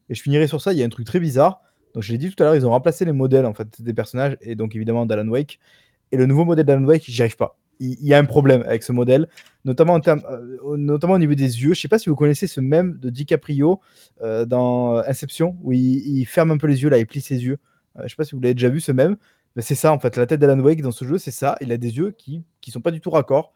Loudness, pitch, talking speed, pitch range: -19 LUFS, 140 Hz, 305 wpm, 125-155 Hz